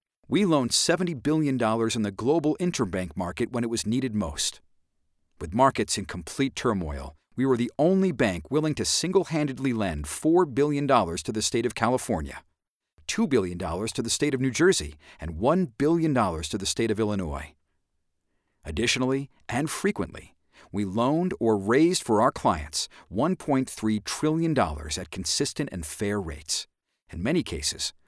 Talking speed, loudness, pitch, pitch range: 155 wpm, -26 LUFS, 115 Hz, 95-140 Hz